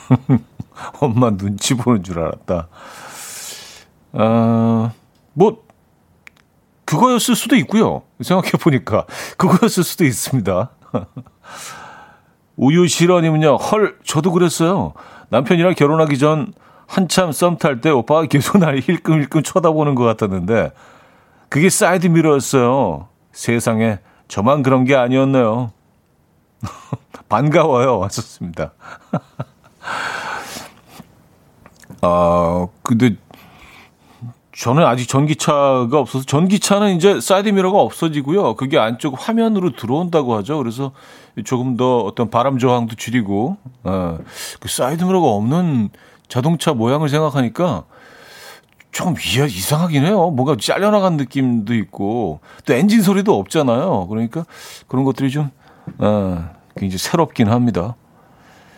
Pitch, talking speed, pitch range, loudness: 140 Hz, 255 characters per minute, 115-170 Hz, -16 LUFS